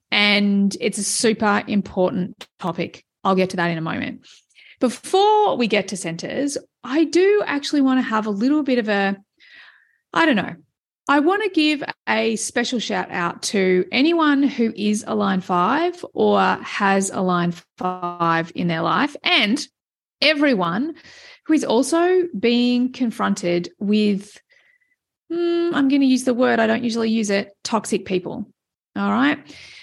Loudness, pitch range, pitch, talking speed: -20 LUFS, 200-290 Hz, 230 Hz, 160 wpm